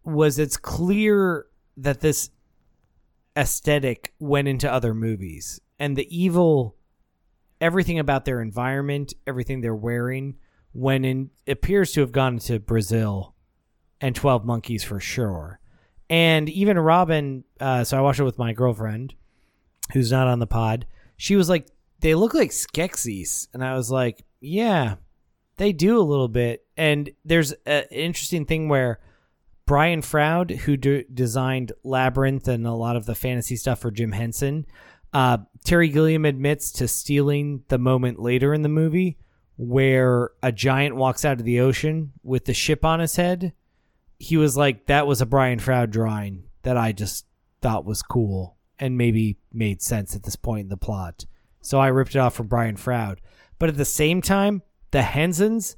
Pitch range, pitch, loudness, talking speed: 115-150 Hz, 130 Hz, -22 LUFS, 165 wpm